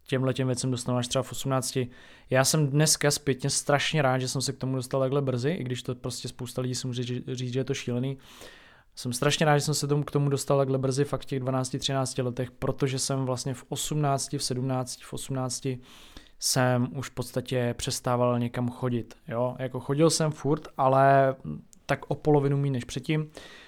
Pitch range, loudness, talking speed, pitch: 125-140 Hz, -27 LUFS, 200 wpm, 130 Hz